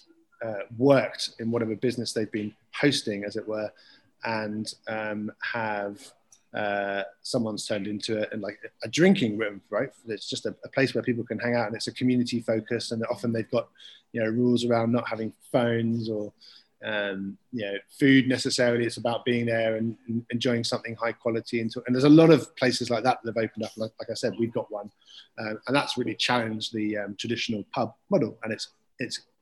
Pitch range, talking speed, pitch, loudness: 110-125 Hz, 200 wpm, 115 Hz, -27 LUFS